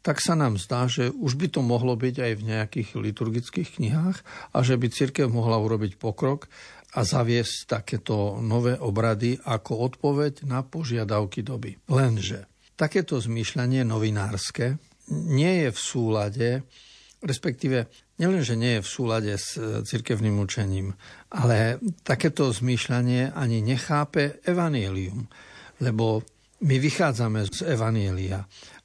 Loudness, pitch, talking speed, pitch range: -26 LUFS, 120 Hz, 125 wpm, 110-135 Hz